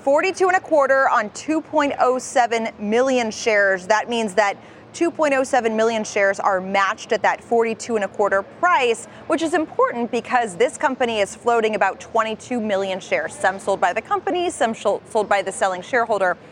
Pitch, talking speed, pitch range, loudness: 230 Hz, 165 wpm, 205-280 Hz, -20 LUFS